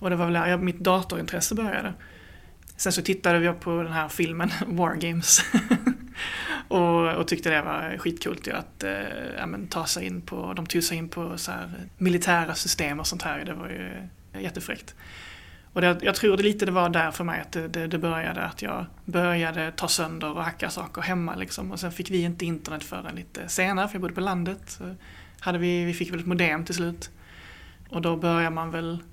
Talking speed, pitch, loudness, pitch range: 210 wpm, 170 Hz, -26 LUFS, 150-180 Hz